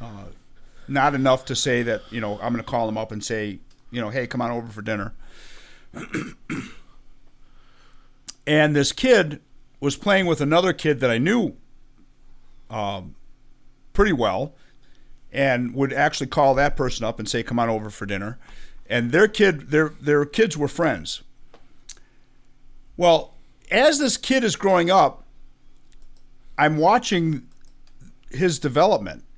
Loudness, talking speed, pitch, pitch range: -21 LUFS, 145 wpm, 130 Hz, 120-150 Hz